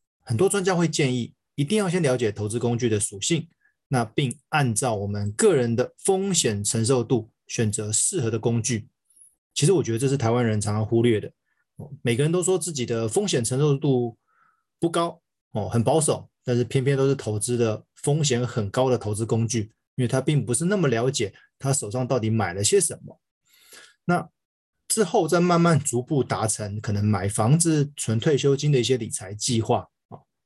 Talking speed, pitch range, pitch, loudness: 275 characters per minute, 115-150 Hz, 125 Hz, -23 LUFS